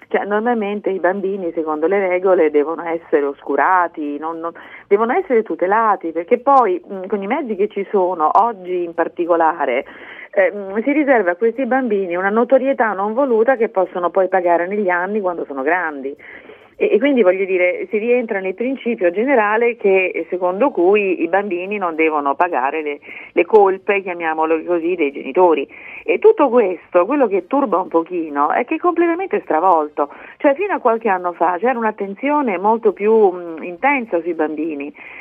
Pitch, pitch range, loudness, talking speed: 190 Hz, 170-245 Hz, -17 LUFS, 165 wpm